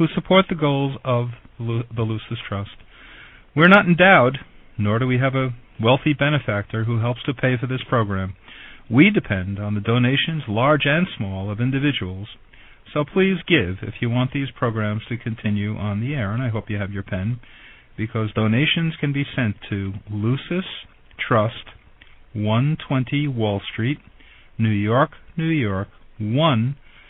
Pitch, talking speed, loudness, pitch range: 120 Hz, 160 wpm, -21 LUFS, 105-140 Hz